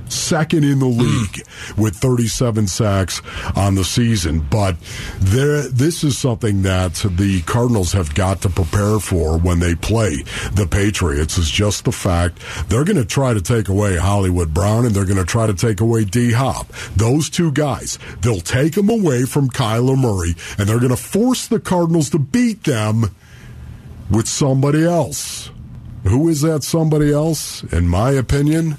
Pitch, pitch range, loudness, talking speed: 115 Hz, 95-140 Hz, -17 LUFS, 170 wpm